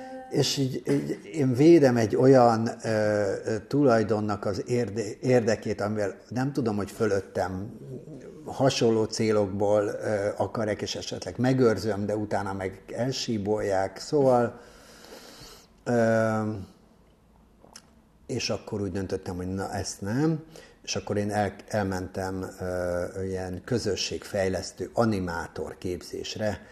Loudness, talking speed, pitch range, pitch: -27 LUFS, 105 wpm, 100-120 Hz, 110 Hz